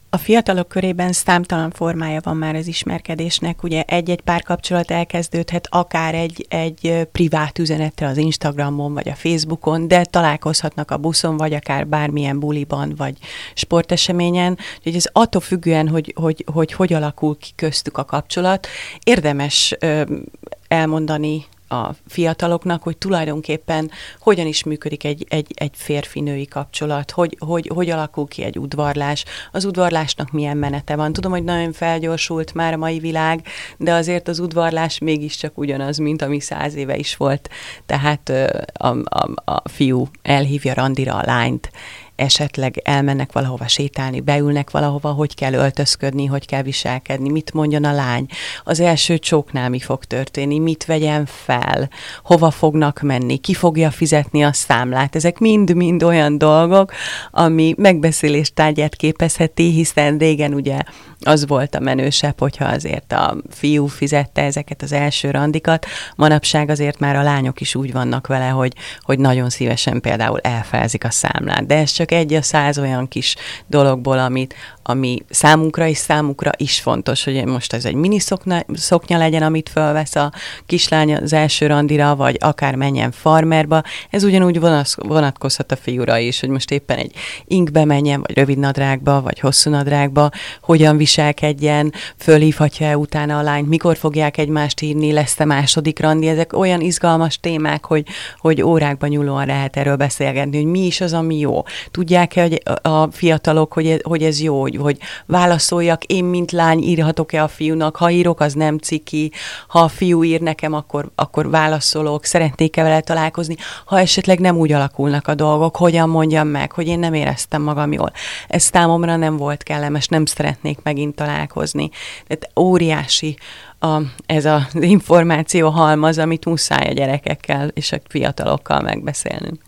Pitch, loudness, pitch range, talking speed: 155 Hz, -17 LUFS, 145-165 Hz, 155 wpm